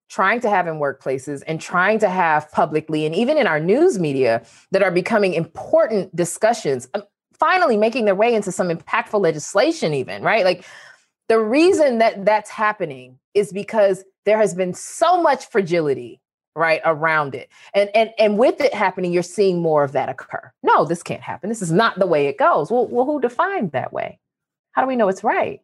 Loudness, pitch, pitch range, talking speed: -19 LUFS, 200 Hz, 165-225 Hz, 195 wpm